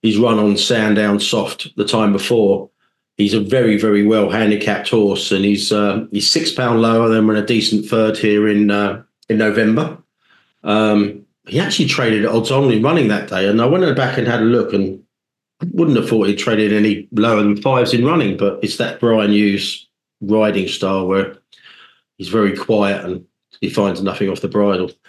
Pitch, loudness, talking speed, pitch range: 105 Hz, -15 LUFS, 195 wpm, 100-115 Hz